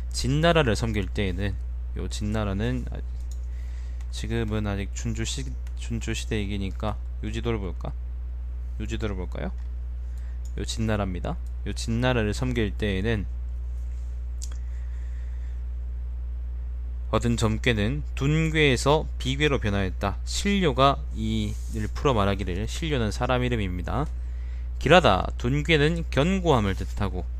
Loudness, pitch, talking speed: -27 LUFS, 95 Hz, 240 characters per minute